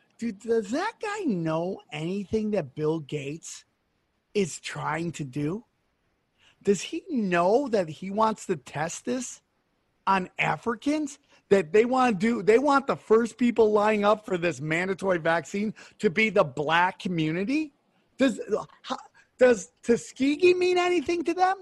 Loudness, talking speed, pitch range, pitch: -26 LUFS, 145 wpm, 175-255 Hz, 215 Hz